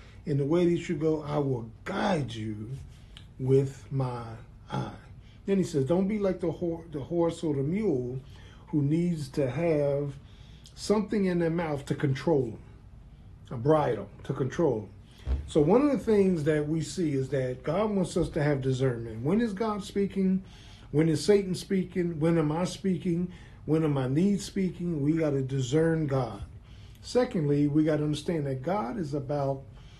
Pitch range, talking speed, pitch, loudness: 130-175 Hz, 180 wpm, 150 Hz, -28 LUFS